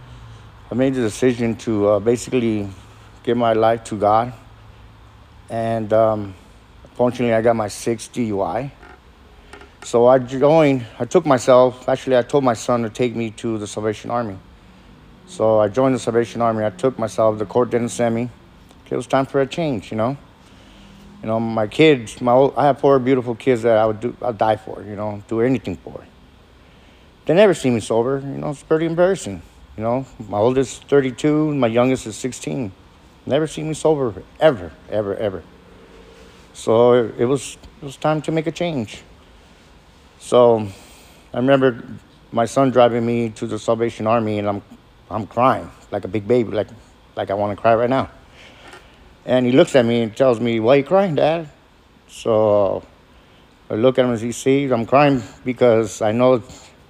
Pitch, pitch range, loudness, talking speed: 115 Hz, 105-130 Hz, -18 LUFS, 180 wpm